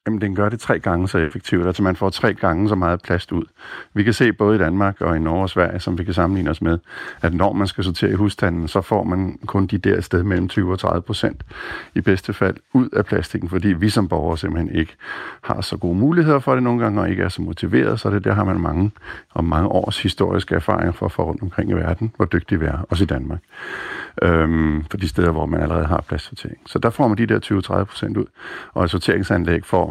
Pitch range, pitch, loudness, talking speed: 85-105 Hz, 95 Hz, -20 LUFS, 255 wpm